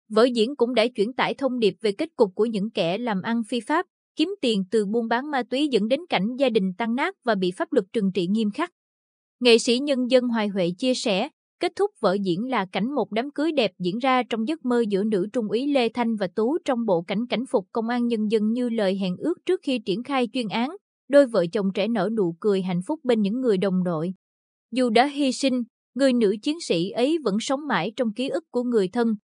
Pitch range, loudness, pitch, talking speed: 205-260 Hz, -24 LUFS, 235 Hz, 250 wpm